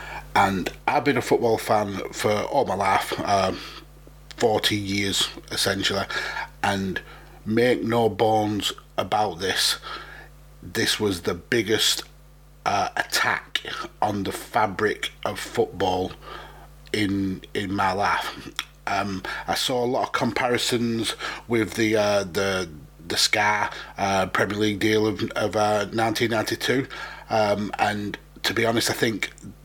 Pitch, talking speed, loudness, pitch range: 105 Hz, 130 wpm, -24 LUFS, 95-110 Hz